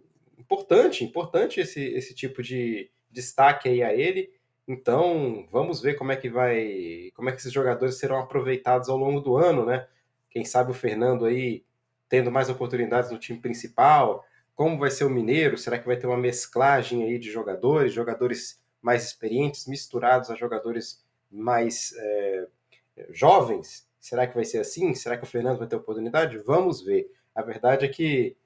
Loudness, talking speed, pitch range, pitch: -25 LUFS, 170 wpm, 120-140 Hz, 125 Hz